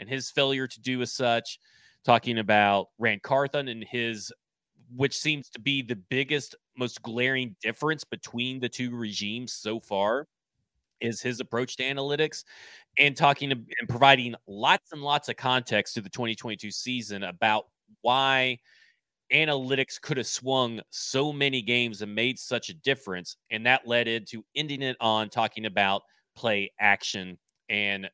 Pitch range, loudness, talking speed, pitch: 110-135 Hz, -27 LUFS, 155 wpm, 120 Hz